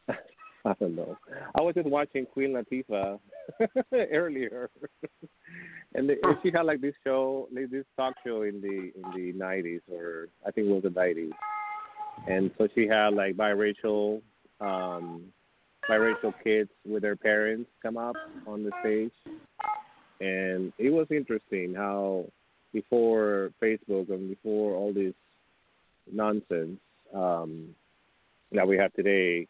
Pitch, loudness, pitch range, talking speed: 105 Hz, -29 LUFS, 95-130 Hz, 135 wpm